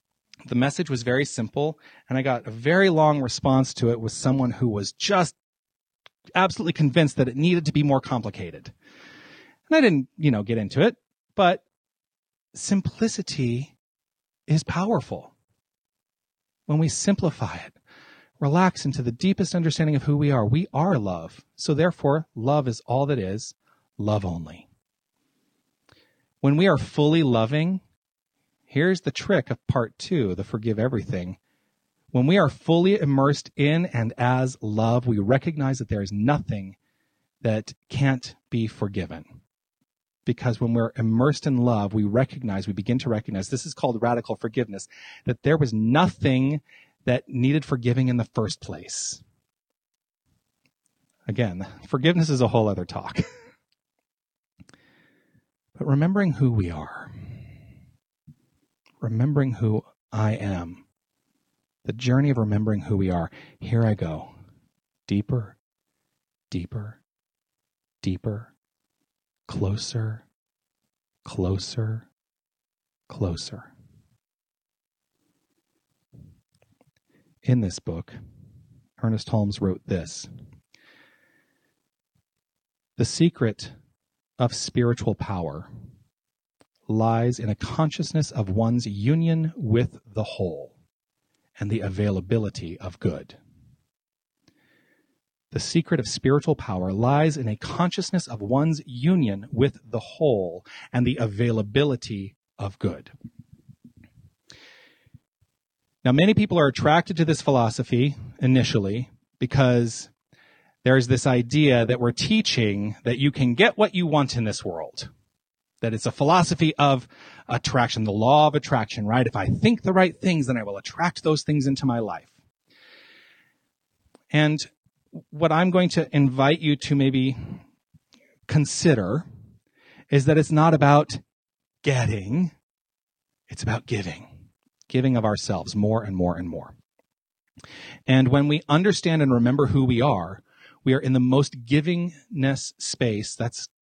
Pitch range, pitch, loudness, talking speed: 110-150 Hz, 130 Hz, -23 LUFS, 125 wpm